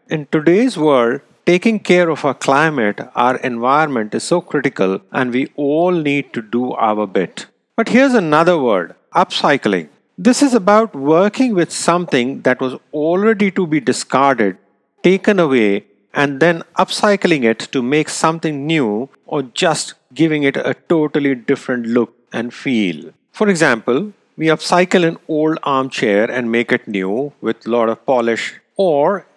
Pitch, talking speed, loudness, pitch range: 150 Hz, 155 wpm, -16 LUFS, 125-175 Hz